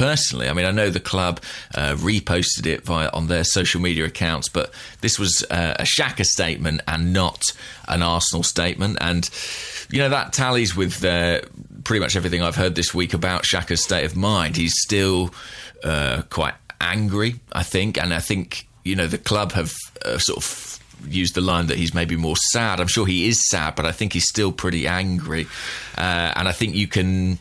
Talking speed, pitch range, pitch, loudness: 200 wpm, 85-100 Hz, 90 Hz, -21 LUFS